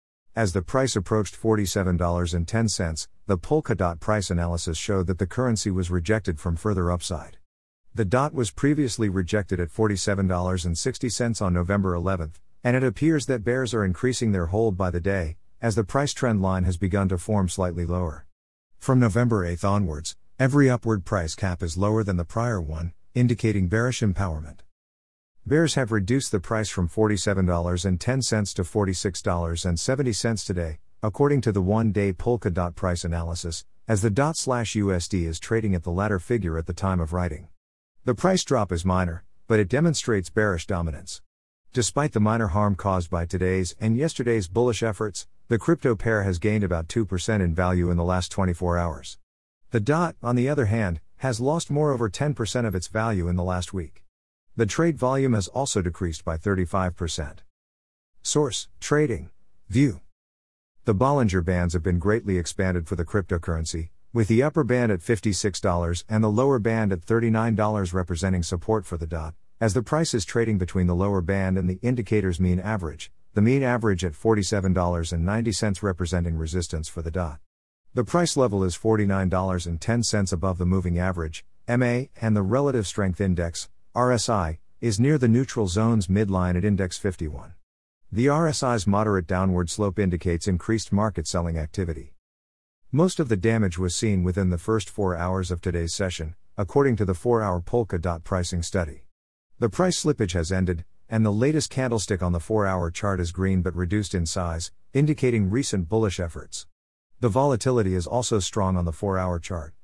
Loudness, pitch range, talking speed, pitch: -25 LUFS, 90-115 Hz, 170 wpm, 95 Hz